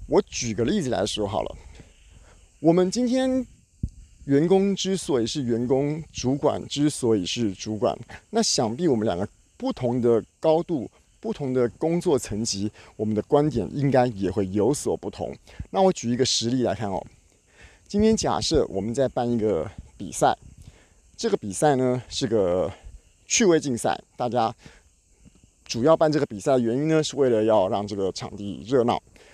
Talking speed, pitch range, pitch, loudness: 240 characters per minute, 110-155 Hz, 125 Hz, -24 LUFS